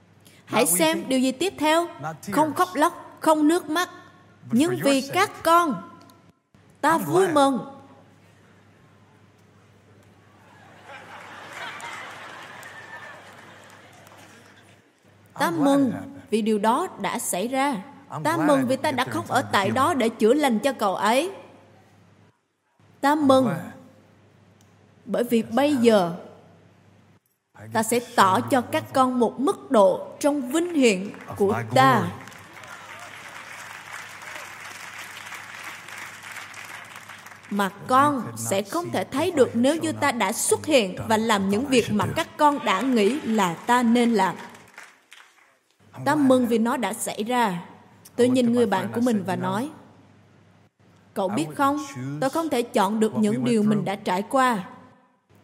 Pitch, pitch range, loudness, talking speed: 240 Hz, 195-285 Hz, -22 LUFS, 125 wpm